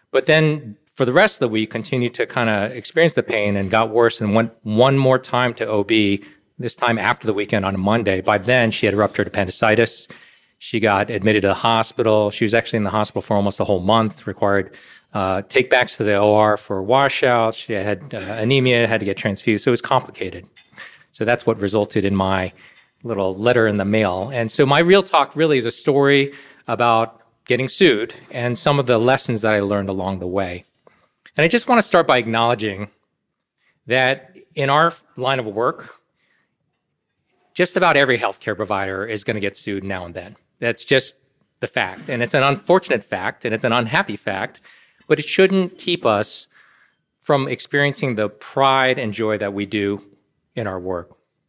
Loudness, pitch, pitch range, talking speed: -18 LUFS, 115 Hz, 105-130 Hz, 195 wpm